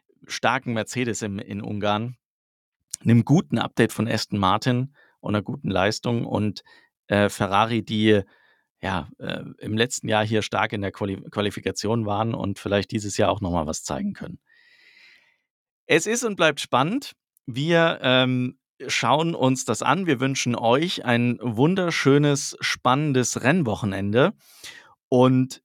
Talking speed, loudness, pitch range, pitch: 140 wpm, -23 LUFS, 105-135 Hz, 115 Hz